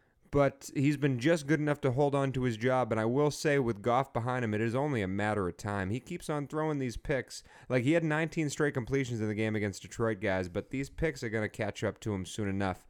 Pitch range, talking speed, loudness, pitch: 110-145 Hz, 265 wpm, -32 LUFS, 125 Hz